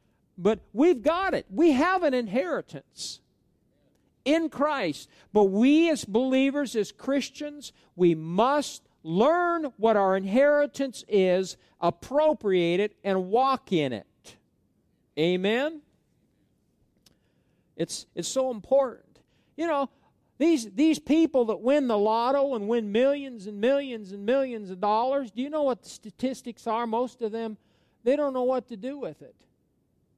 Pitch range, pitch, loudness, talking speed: 210-280 Hz, 250 Hz, -26 LUFS, 140 wpm